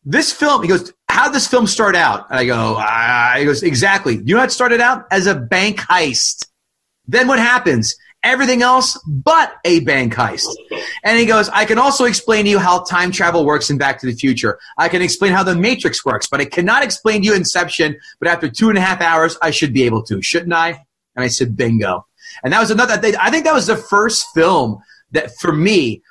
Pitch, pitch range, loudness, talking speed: 190 Hz, 155-245 Hz, -14 LUFS, 230 wpm